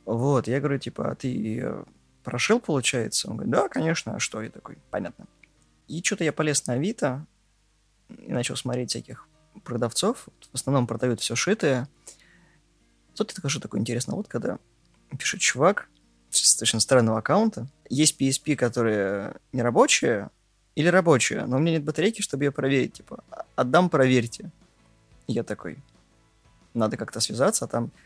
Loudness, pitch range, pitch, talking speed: -24 LUFS, 115-155 Hz, 130 Hz, 160 wpm